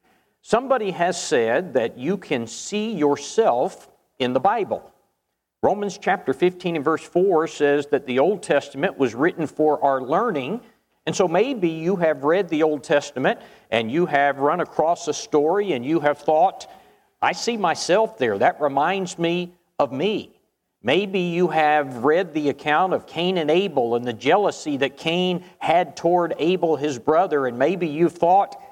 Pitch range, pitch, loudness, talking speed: 145-190 Hz, 170 Hz, -21 LUFS, 165 wpm